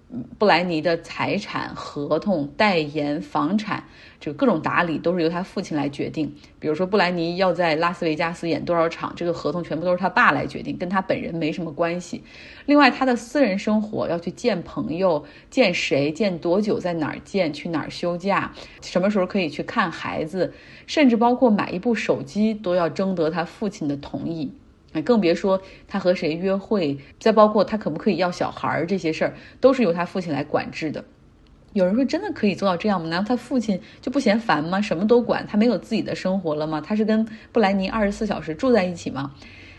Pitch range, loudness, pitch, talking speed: 165-220 Hz, -22 LUFS, 185 Hz, 310 characters per minute